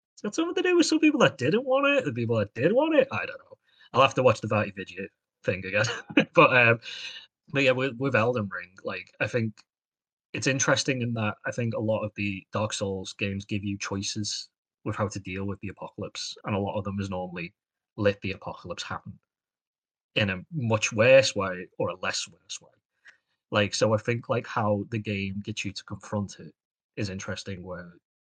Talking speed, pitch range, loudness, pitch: 215 wpm, 100-130 Hz, -26 LUFS, 105 Hz